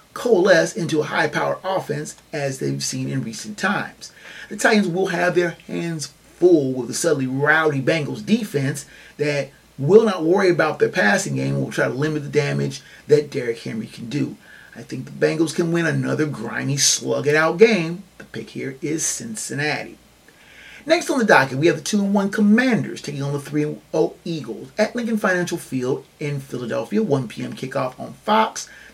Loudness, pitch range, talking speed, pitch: -20 LUFS, 135-190 Hz, 175 wpm, 155 Hz